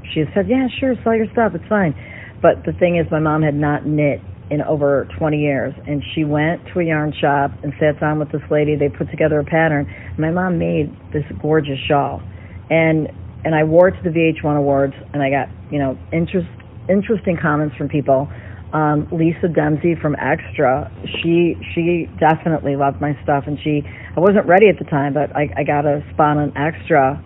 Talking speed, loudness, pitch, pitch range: 205 wpm, -18 LUFS, 150 Hz, 140-165 Hz